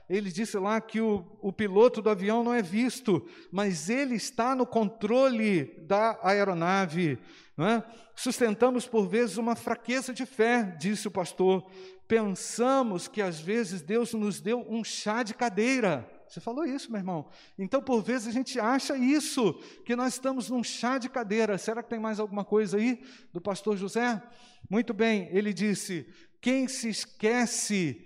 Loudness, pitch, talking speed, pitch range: -29 LUFS, 225 Hz, 165 wpm, 200-240 Hz